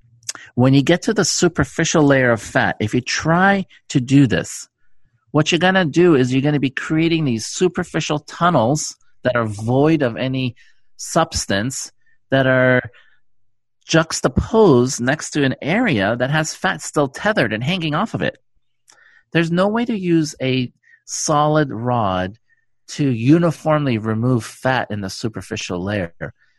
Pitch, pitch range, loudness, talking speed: 135 Hz, 120-165 Hz, -18 LUFS, 155 wpm